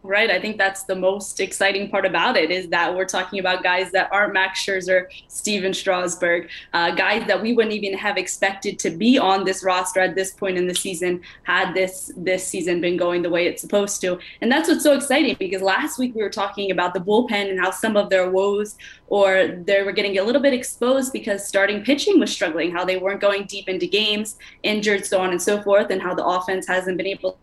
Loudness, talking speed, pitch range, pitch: -20 LUFS, 230 wpm, 185-205 Hz, 195 Hz